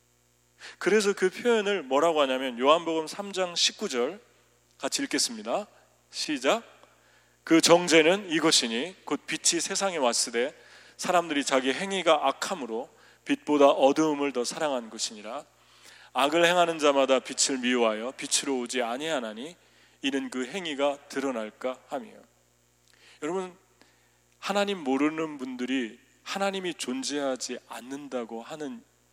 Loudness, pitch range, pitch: -26 LUFS, 130-180 Hz, 145 Hz